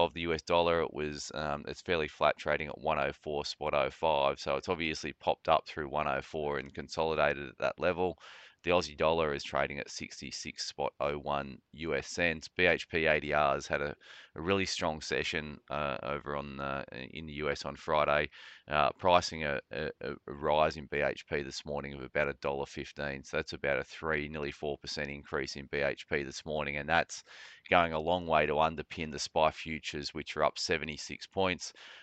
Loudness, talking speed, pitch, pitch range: -33 LUFS, 180 wpm, 75 Hz, 70-80 Hz